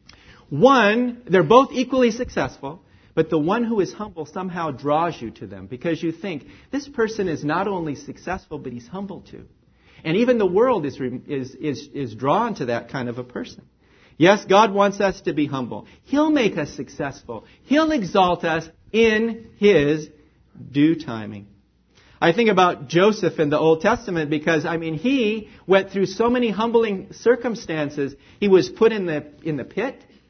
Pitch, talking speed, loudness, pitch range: 170 Hz, 175 wpm, -21 LUFS, 145-215 Hz